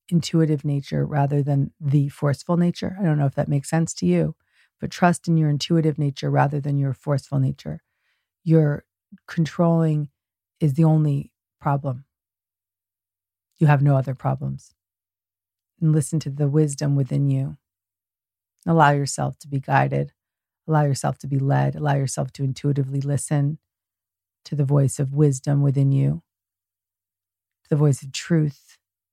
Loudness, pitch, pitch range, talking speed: -22 LUFS, 140 Hz, 95-150 Hz, 145 wpm